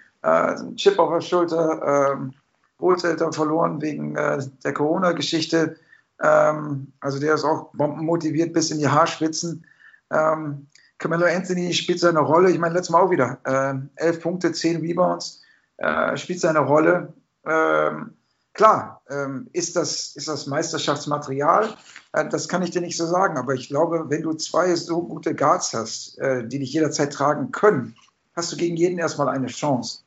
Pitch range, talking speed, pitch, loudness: 140-170 Hz, 165 wpm, 155 Hz, -22 LUFS